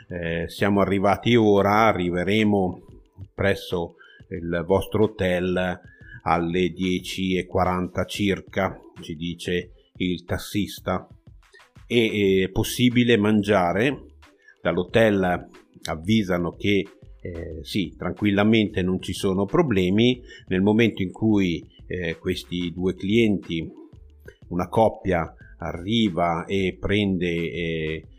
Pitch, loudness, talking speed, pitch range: 95 Hz, -23 LUFS, 95 wpm, 90-105 Hz